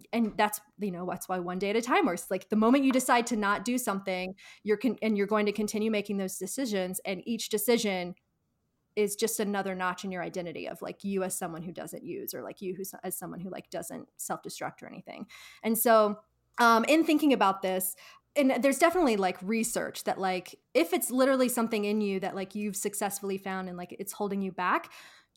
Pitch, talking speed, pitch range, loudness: 205 Hz, 220 wpm, 185-230 Hz, -29 LUFS